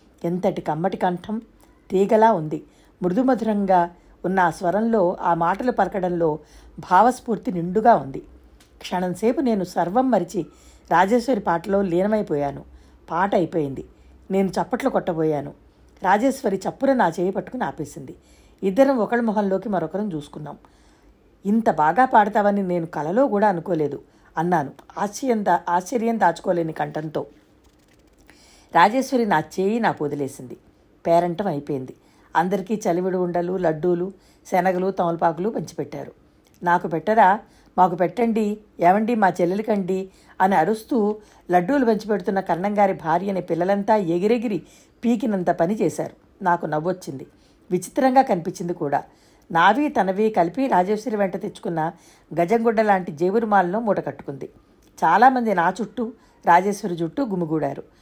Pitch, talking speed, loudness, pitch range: 190 Hz, 105 wpm, -21 LUFS, 170-220 Hz